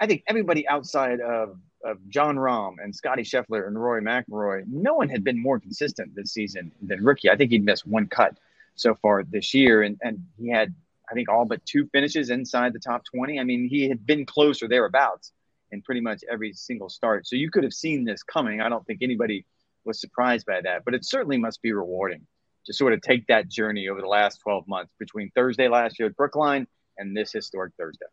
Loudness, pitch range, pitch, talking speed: -24 LUFS, 105-135 Hz, 120 Hz, 220 wpm